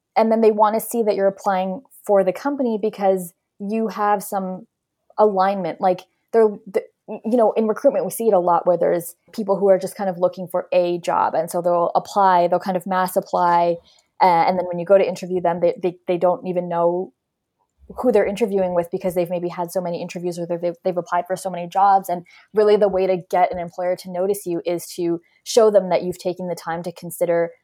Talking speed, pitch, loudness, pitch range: 230 wpm, 185 Hz, -20 LUFS, 175-205 Hz